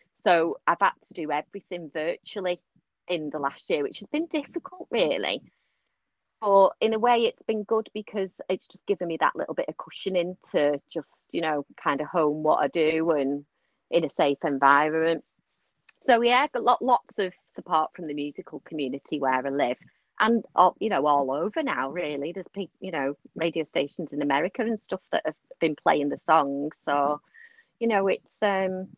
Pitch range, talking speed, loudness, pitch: 150-225 Hz, 190 wpm, -26 LUFS, 180 Hz